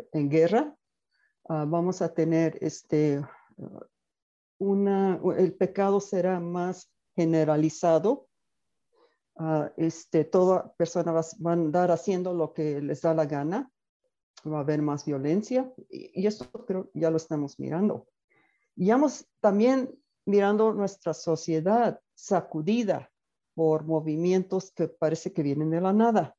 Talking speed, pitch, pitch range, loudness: 130 wpm, 175 Hz, 160-200 Hz, -27 LUFS